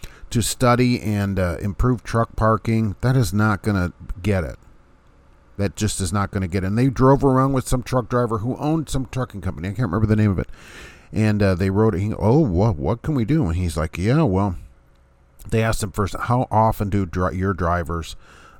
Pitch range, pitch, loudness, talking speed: 95-120 Hz, 105 Hz, -21 LUFS, 225 wpm